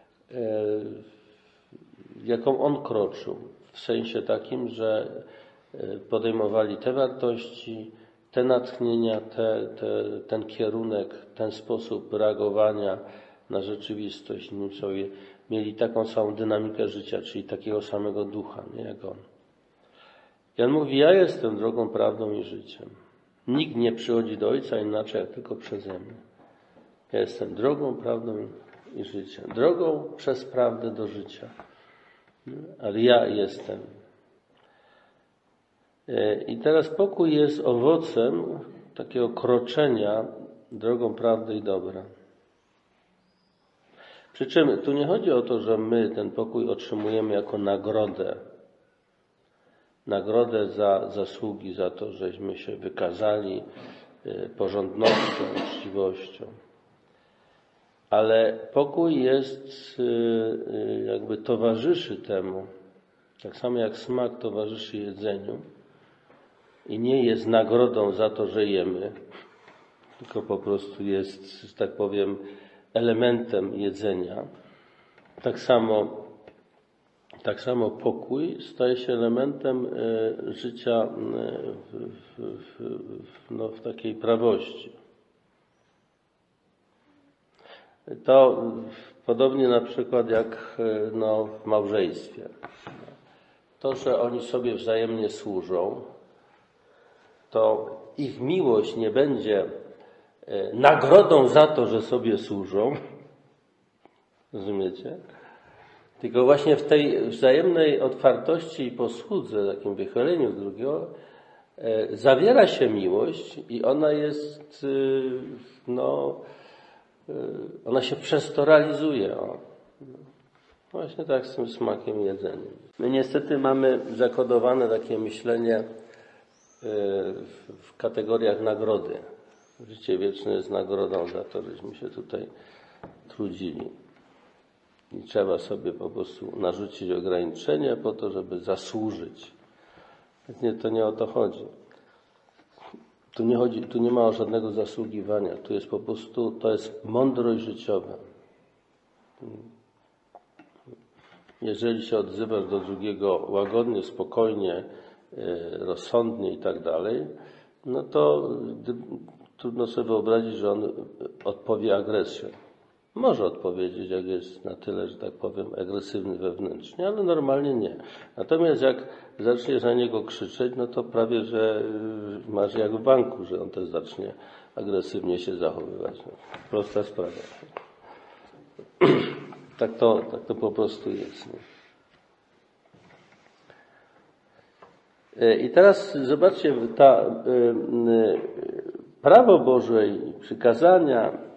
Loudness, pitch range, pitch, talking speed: -25 LUFS, 110-150 Hz, 120 Hz, 100 wpm